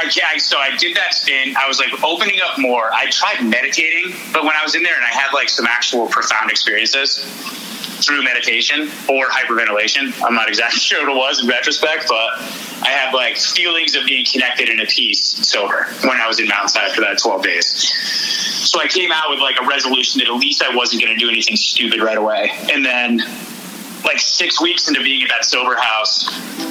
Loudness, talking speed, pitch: -14 LUFS, 210 wpm, 195 Hz